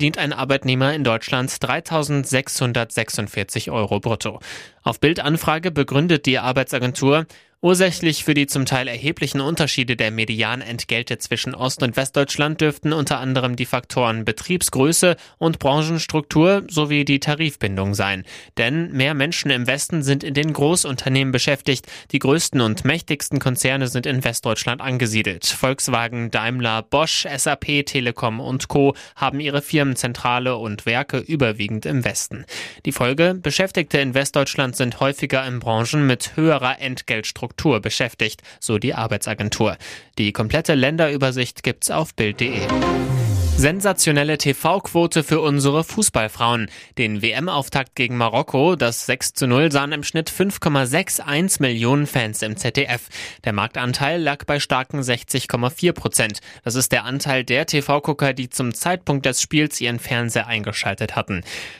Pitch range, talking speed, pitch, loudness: 120-145 Hz, 135 wpm, 135 Hz, -20 LUFS